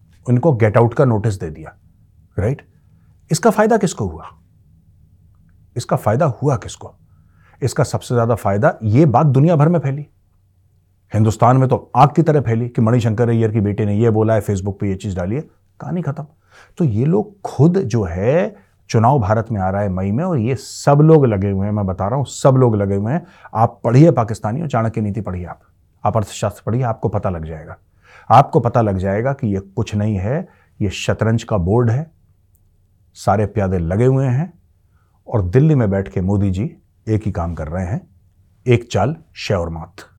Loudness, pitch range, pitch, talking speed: -17 LUFS, 95-130 Hz, 110 Hz, 195 wpm